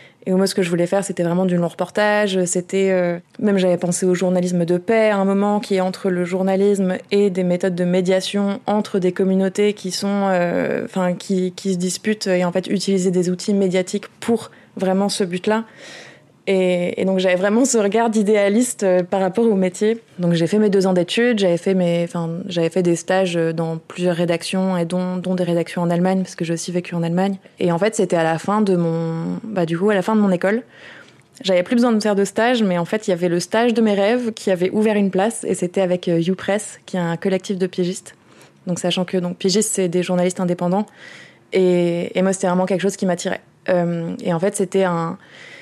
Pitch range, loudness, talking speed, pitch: 180-200 Hz, -19 LUFS, 230 wpm, 190 Hz